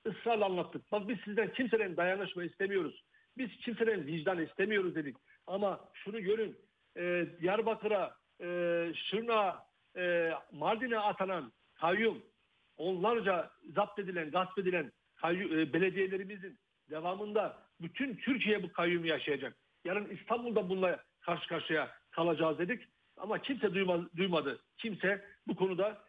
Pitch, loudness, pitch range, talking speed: 190 Hz, -35 LUFS, 175-210 Hz, 110 wpm